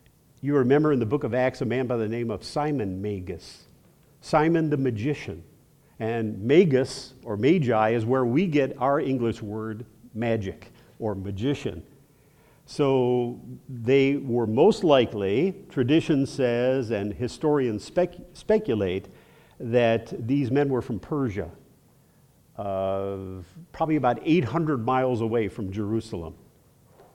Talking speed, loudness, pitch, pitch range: 125 wpm, -25 LUFS, 125 Hz, 110-145 Hz